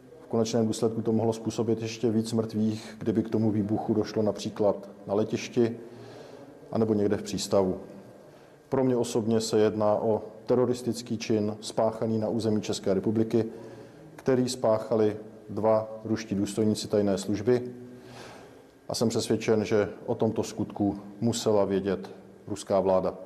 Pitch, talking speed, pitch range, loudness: 110 Hz, 130 wpm, 105-115 Hz, -28 LUFS